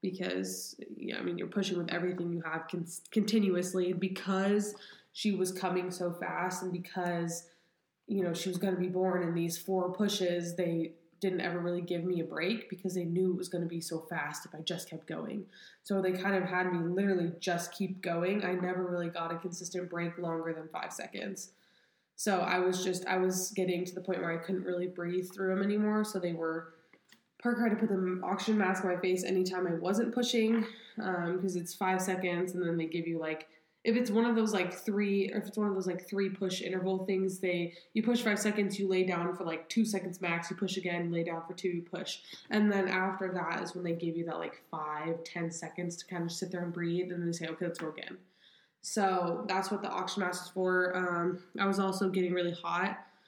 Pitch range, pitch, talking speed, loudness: 175-190 Hz, 180 Hz, 230 wpm, -34 LUFS